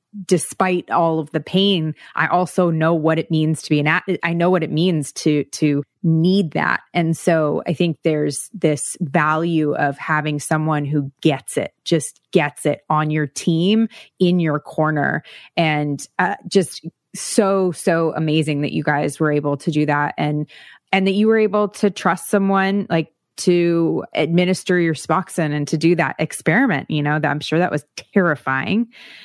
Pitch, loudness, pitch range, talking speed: 160 Hz, -19 LUFS, 150-180 Hz, 175 wpm